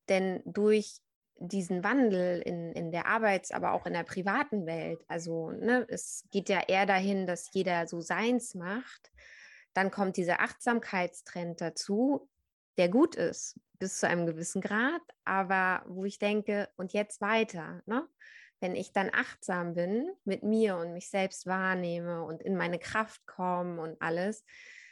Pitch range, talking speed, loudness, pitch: 175-215 Hz, 155 wpm, -32 LUFS, 190 Hz